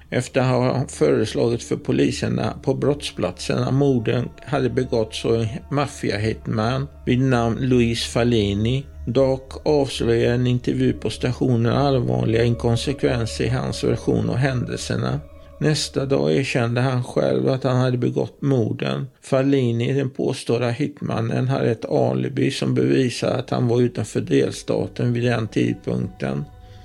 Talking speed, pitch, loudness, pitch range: 130 wpm, 120 Hz, -21 LUFS, 105-130 Hz